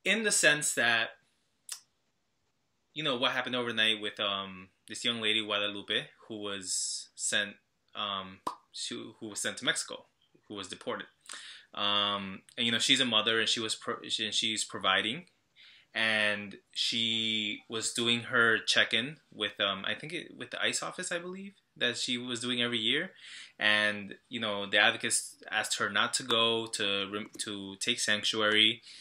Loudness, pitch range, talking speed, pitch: -29 LUFS, 105-120 Hz, 165 wpm, 110 Hz